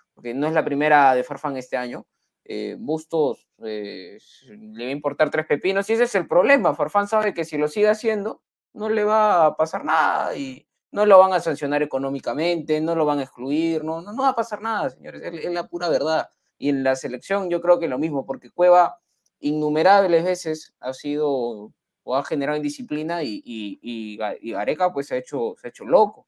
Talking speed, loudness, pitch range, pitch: 210 wpm, -22 LUFS, 140-190 Hz, 155 Hz